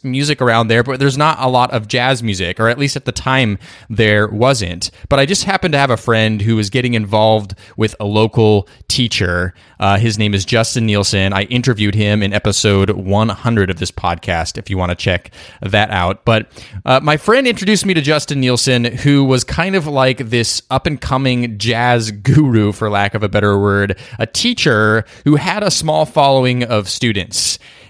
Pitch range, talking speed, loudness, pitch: 105-130 Hz, 200 wpm, -14 LUFS, 115 Hz